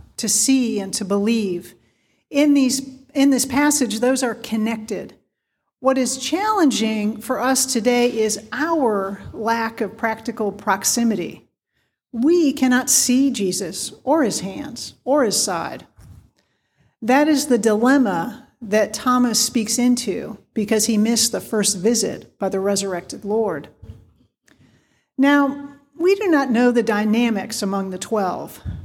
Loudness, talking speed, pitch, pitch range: -19 LUFS, 130 wpm, 235 Hz, 210-265 Hz